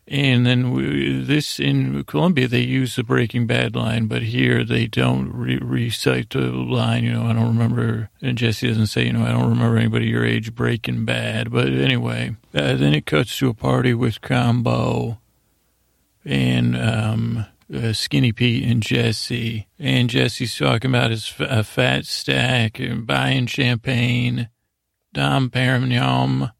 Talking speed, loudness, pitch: 160 wpm, -20 LUFS, 115 Hz